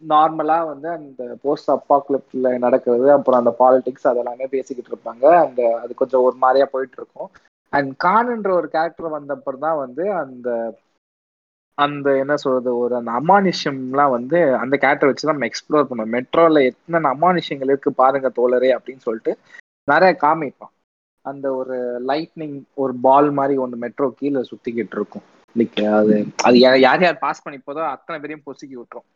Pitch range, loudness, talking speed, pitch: 125-150 Hz, -18 LUFS, 150 wpm, 135 Hz